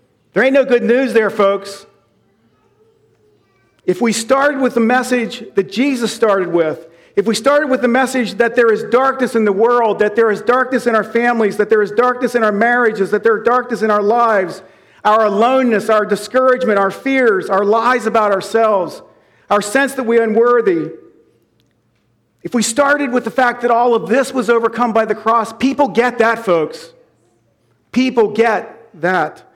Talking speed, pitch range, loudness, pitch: 180 wpm, 210-250 Hz, -14 LUFS, 230 Hz